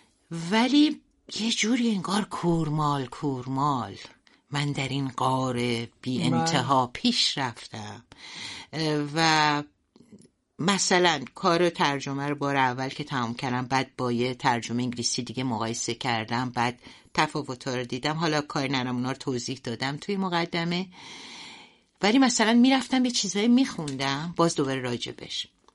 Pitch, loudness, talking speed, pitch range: 140 Hz, -26 LUFS, 130 wpm, 125-175 Hz